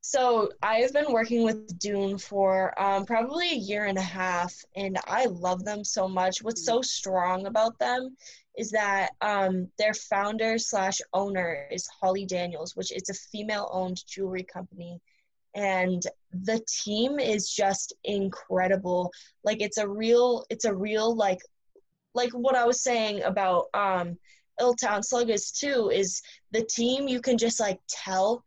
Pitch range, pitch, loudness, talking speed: 185-230 Hz, 205 Hz, -27 LUFS, 155 wpm